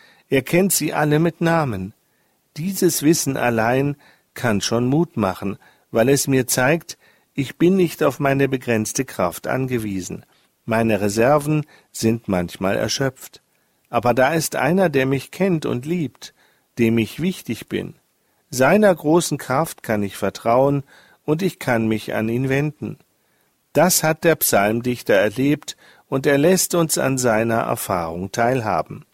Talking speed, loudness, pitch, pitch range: 140 wpm, -20 LUFS, 135 Hz, 115-160 Hz